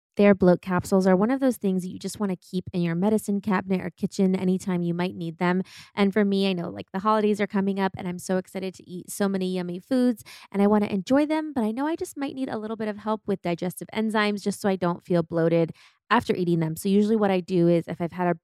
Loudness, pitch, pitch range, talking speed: -25 LUFS, 190 Hz, 180-210 Hz, 280 wpm